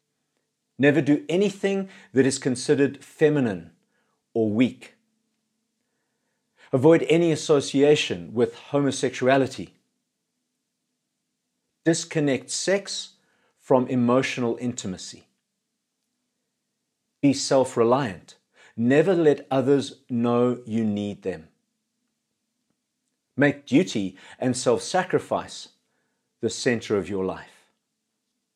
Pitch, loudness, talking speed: 150 Hz, -23 LUFS, 80 wpm